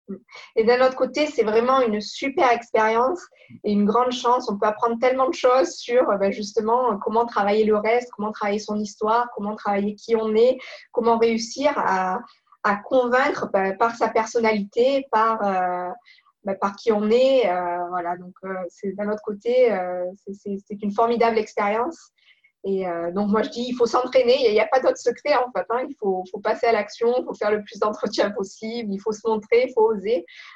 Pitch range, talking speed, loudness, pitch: 205-245 Hz, 200 wpm, -22 LUFS, 225 Hz